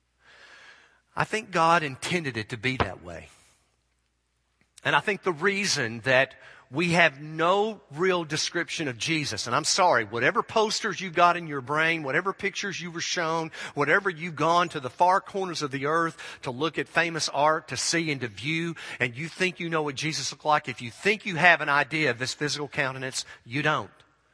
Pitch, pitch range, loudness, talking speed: 155 Hz, 130-175 Hz, -26 LUFS, 195 wpm